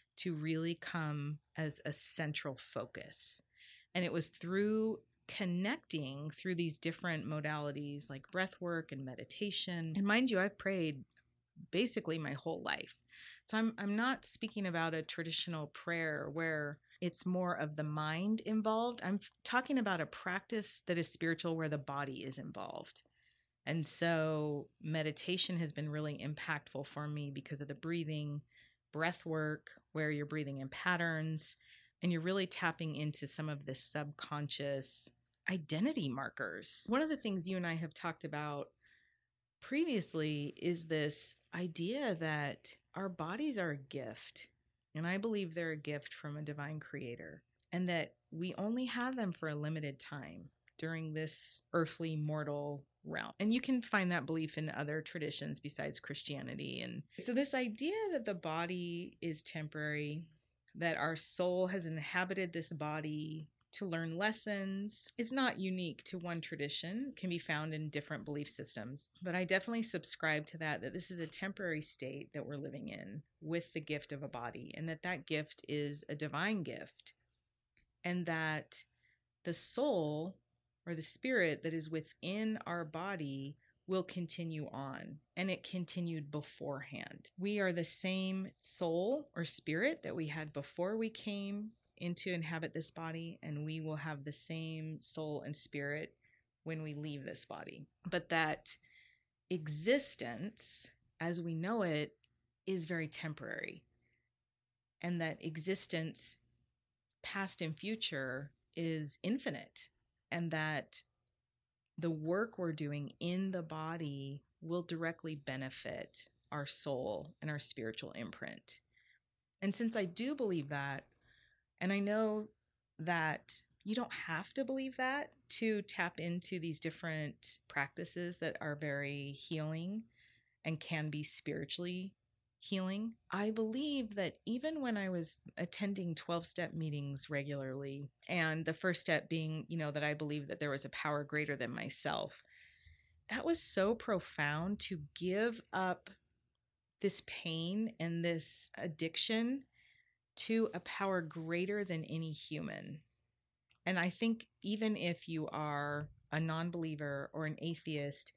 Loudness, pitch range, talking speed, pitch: -37 LUFS, 150-185 Hz, 145 wpm, 165 Hz